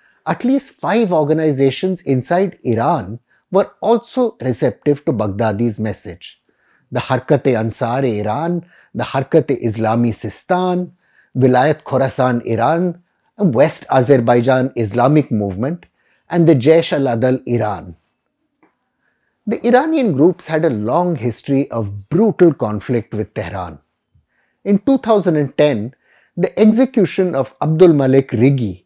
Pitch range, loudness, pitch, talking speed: 115-175 Hz, -16 LUFS, 135 Hz, 110 wpm